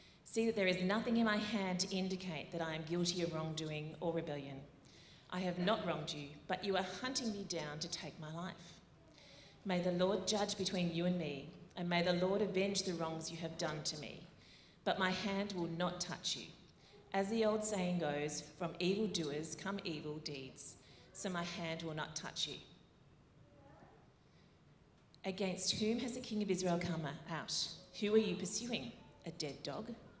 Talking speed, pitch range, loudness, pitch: 185 wpm, 160-195 Hz, -39 LUFS, 180 Hz